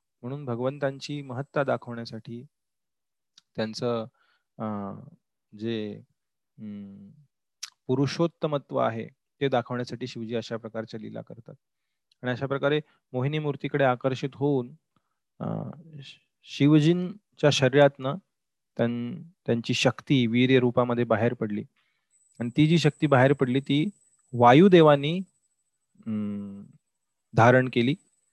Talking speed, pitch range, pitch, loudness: 85 wpm, 120-150 Hz, 135 Hz, -25 LUFS